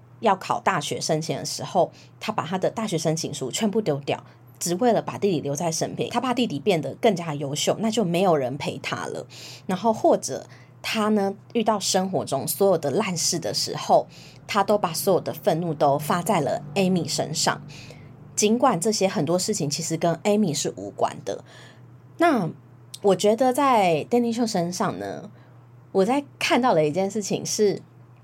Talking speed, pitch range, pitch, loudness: 260 characters per minute, 145-215 Hz, 175 Hz, -24 LUFS